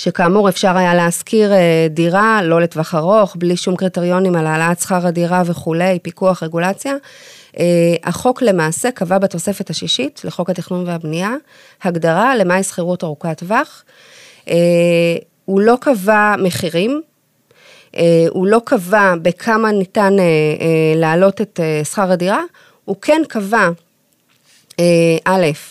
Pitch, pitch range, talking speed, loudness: 180 Hz, 170-210 Hz, 115 wpm, -14 LUFS